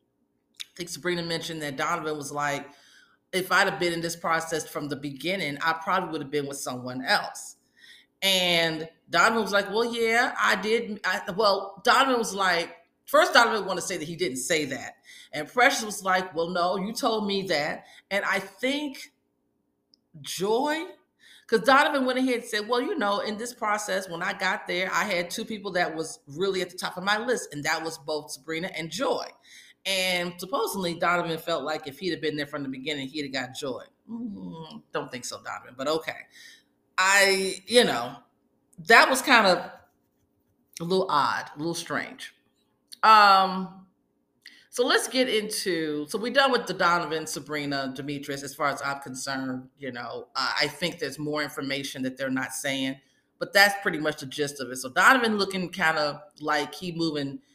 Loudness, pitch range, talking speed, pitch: -25 LUFS, 150-205 Hz, 190 wpm, 175 Hz